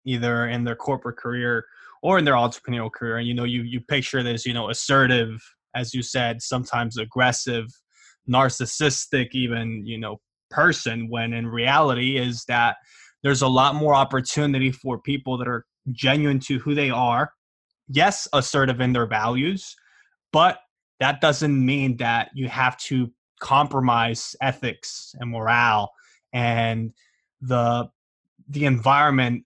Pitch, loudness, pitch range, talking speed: 125 Hz, -22 LUFS, 120-135 Hz, 145 wpm